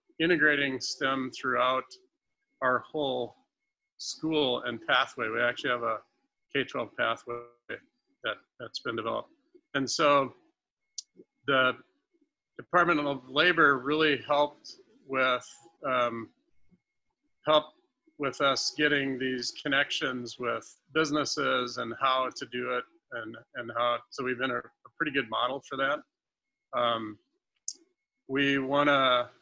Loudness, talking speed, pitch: -29 LUFS, 120 wpm, 145 Hz